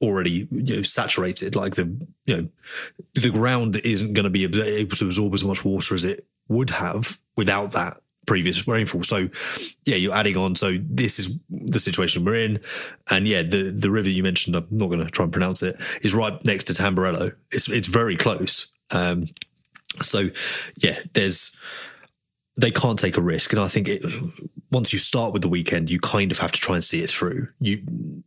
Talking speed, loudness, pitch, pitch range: 200 wpm, -22 LUFS, 100 Hz, 90-115 Hz